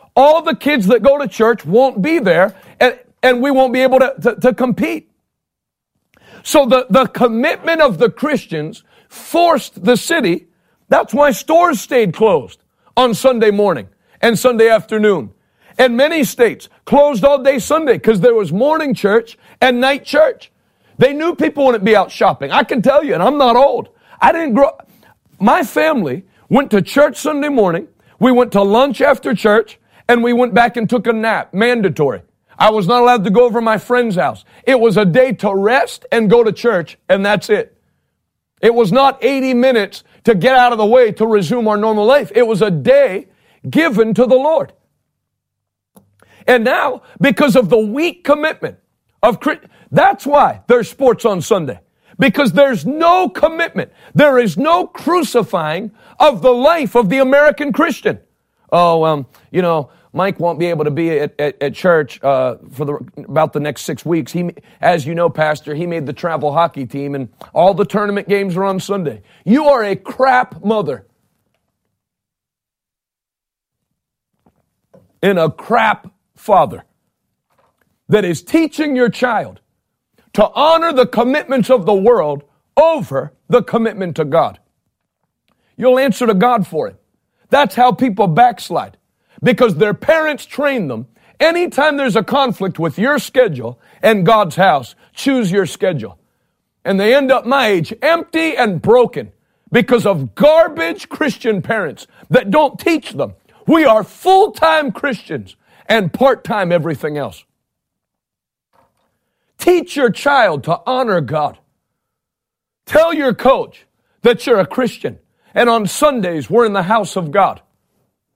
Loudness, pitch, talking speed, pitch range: -13 LUFS, 240 Hz, 160 wpm, 195-275 Hz